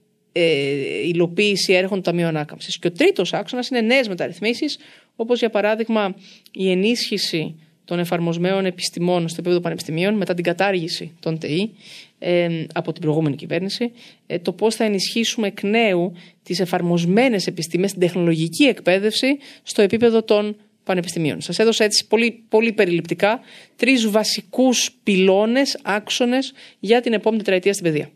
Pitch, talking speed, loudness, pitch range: 195 Hz, 145 wpm, -20 LUFS, 175-225 Hz